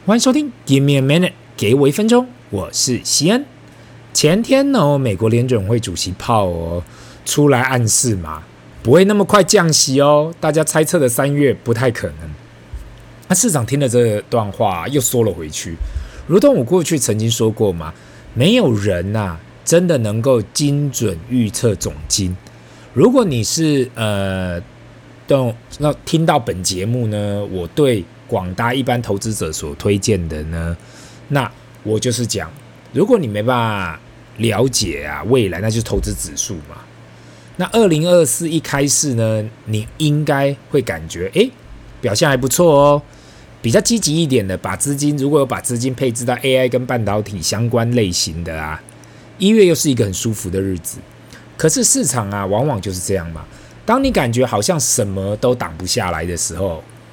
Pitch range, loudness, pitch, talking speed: 100-145 Hz, -16 LUFS, 120 Hz, 260 characters per minute